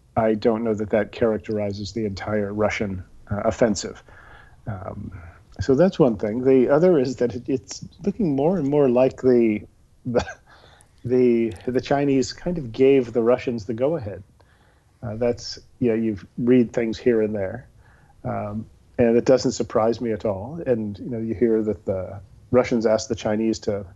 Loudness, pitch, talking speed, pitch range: -22 LUFS, 115 Hz, 170 wpm, 105-125 Hz